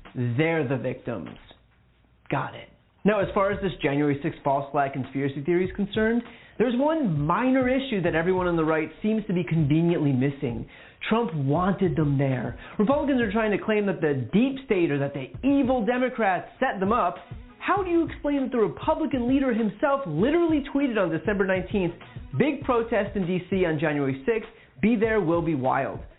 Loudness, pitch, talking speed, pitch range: -25 LUFS, 195 Hz, 180 wpm, 155-240 Hz